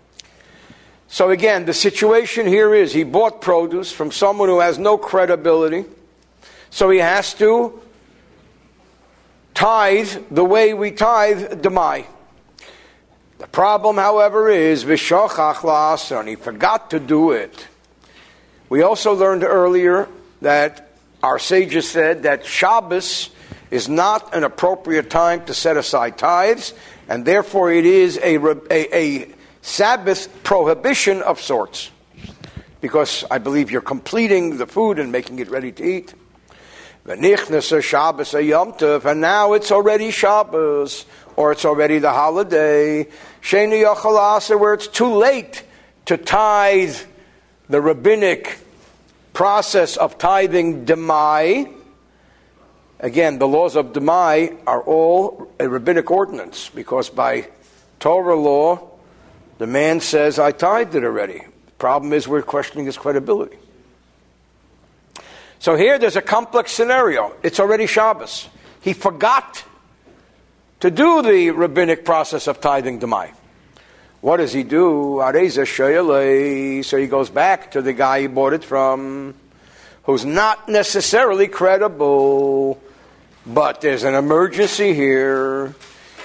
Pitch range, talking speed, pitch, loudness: 145-210 Hz, 120 wpm, 170 Hz, -16 LUFS